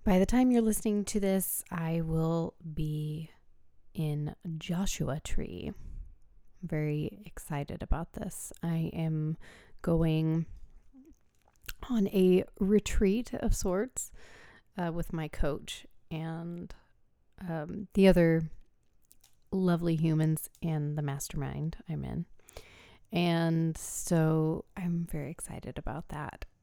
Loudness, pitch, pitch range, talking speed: -32 LUFS, 165 Hz, 160-190 Hz, 110 wpm